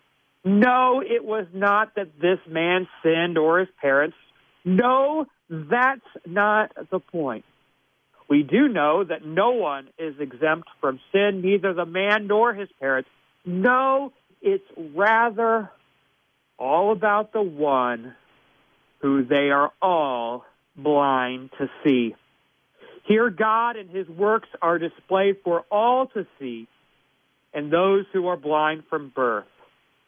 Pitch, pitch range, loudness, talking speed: 185 Hz, 150-215 Hz, -22 LUFS, 130 wpm